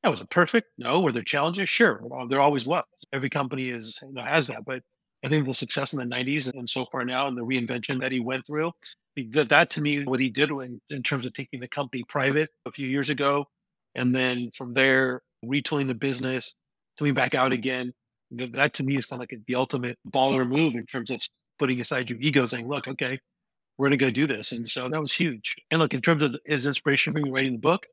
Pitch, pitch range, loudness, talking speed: 135 Hz, 125-145 Hz, -26 LUFS, 230 wpm